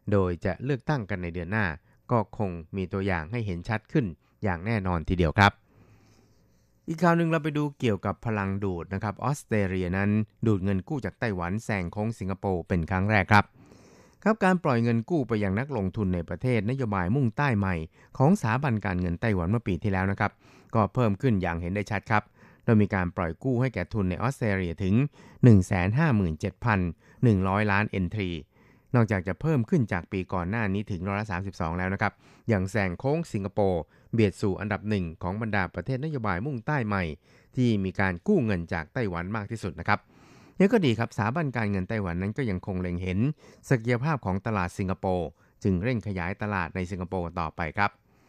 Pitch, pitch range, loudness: 100 Hz, 95-115 Hz, -27 LUFS